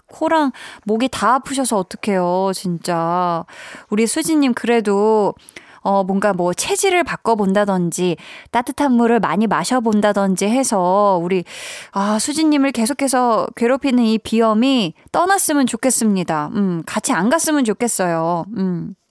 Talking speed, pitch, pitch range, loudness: 285 characters per minute, 220 Hz, 190-260 Hz, -17 LUFS